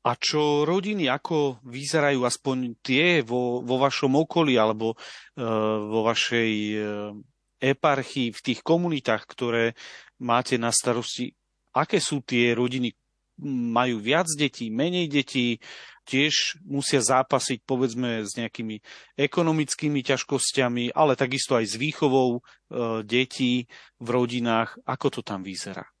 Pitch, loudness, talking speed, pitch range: 125 Hz, -25 LUFS, 120 wpm, 115-140 Hz